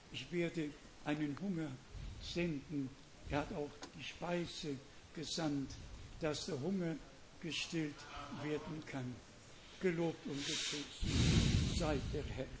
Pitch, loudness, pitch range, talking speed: 145 Hz, -41 LUFS, 135-160 Hz, 110 wpm